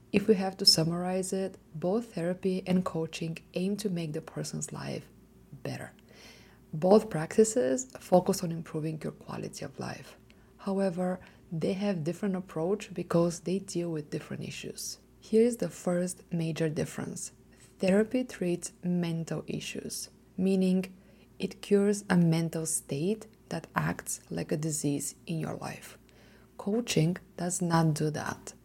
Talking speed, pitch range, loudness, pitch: 140 wpm, 160-195 Hz, -31 LUFS, 180 Hz